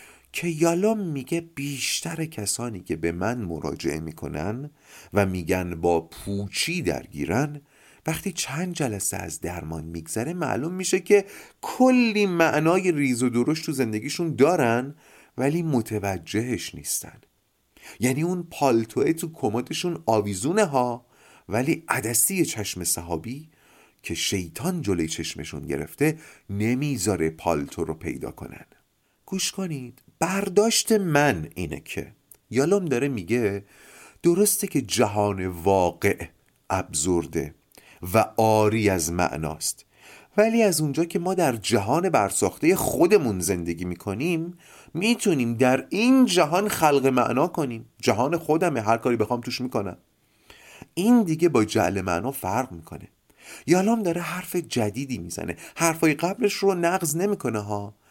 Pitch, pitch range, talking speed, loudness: 130 Hz, 100-170 Hz, 120 wpm, -24 LUFS